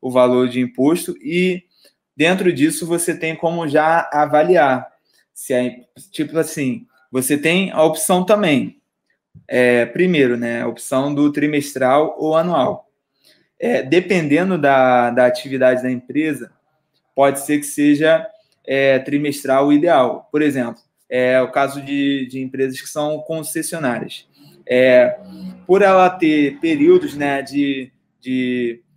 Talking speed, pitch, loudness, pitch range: 135 wpm, 145 Hz, -17 LUFS, 130-165 Hz